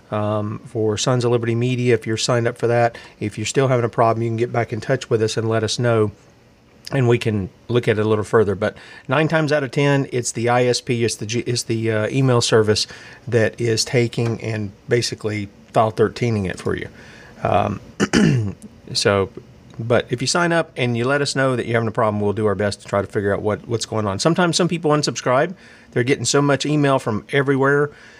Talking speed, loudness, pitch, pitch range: 230 wpm, -19 LUFS, 120 Hz, 110-130 Hz